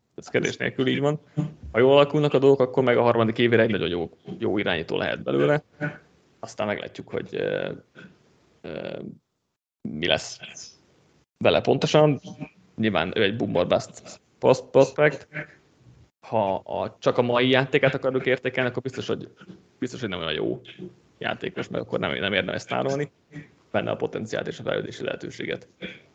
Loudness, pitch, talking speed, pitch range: -24 LUFS, 135 Hz, 145 wpm, 125-150 Hz